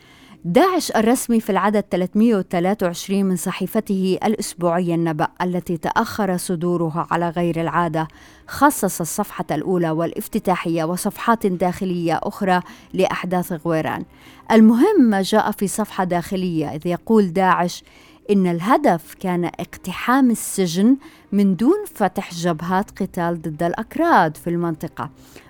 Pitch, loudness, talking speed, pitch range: 185 Hz, -20 LUFS, 110 wpm, 170-210 Hz